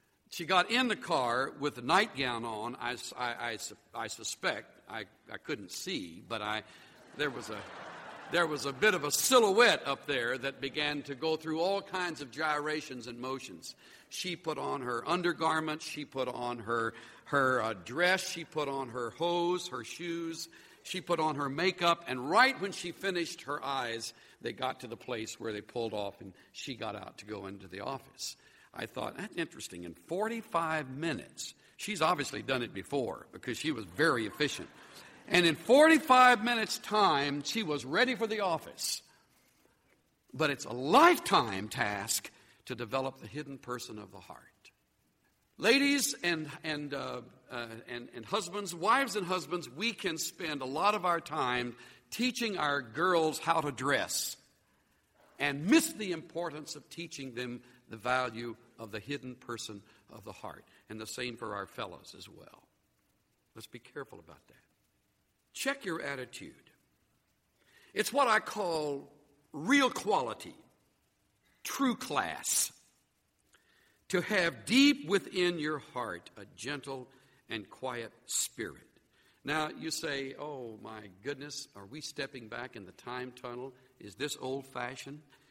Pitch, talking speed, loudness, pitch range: 145 Hz, 160 wpm, -32 LUFS, 125-175 Hz